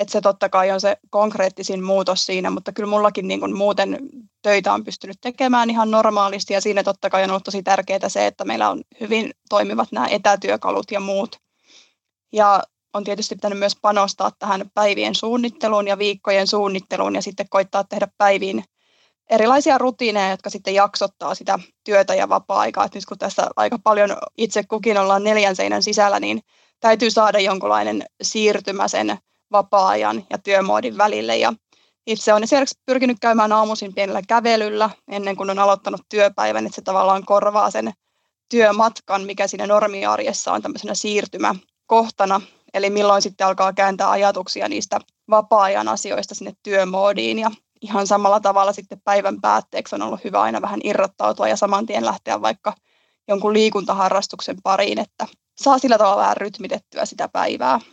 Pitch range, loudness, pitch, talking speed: 195-215 Hz, -19 LUFS, 205 Hz, 155 wpm